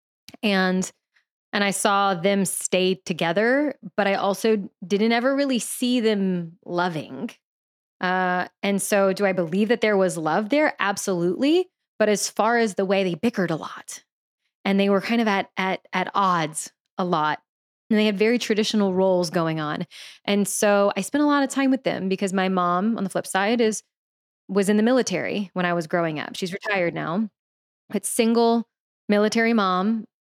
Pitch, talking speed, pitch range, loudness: 200 Hz, 180 wpm, 185-225 Hz, -22 LUFS